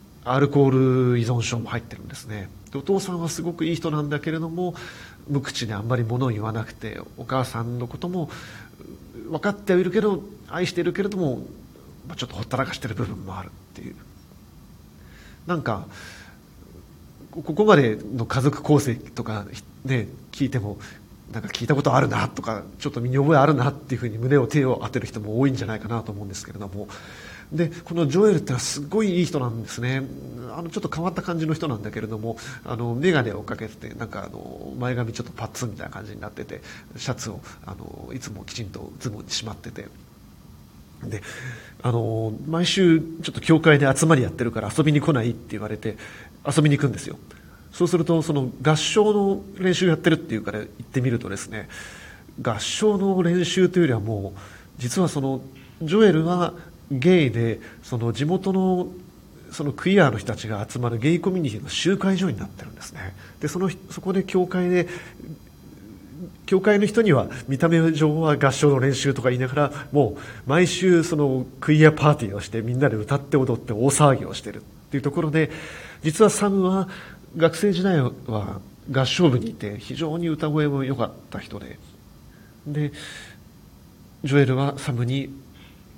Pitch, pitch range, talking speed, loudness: 135 Hz, 115-165 Hz, 370 characters per minute, -23 LUFS